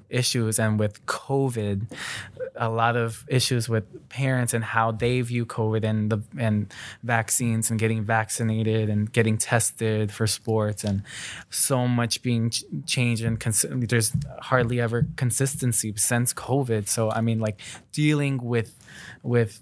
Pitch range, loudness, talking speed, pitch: 110-125 Hz, -24 LUFS, 145 wpm, 115 Hz